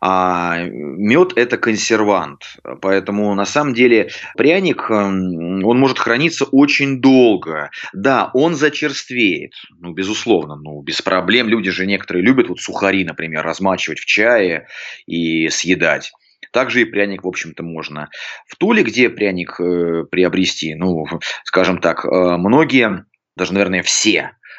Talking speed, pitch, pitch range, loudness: 130 wpm, 95 Hz, 85-110 Hz, -15 LUFS